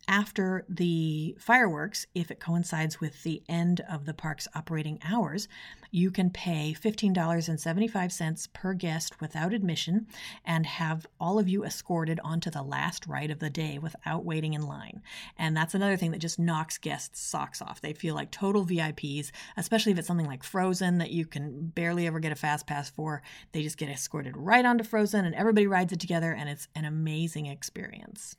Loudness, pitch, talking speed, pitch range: -30 LUFS, 165 Hz, 185 wpm, 155-185 Hz